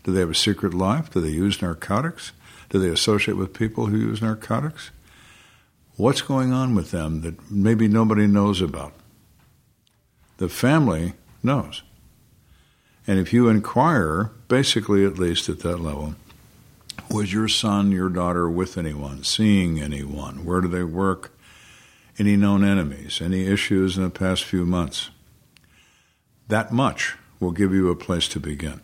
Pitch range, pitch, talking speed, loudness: 85-110 Hz, 95 Hz, 150 wpm, -22 LUFS